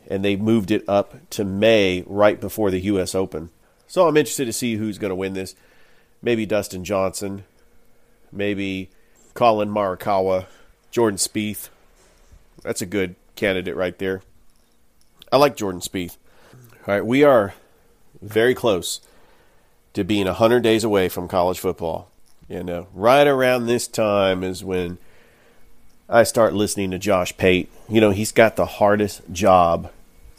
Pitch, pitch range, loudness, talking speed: 100 Hz, 95-110 Hz, -20 LUFS, 150 wpm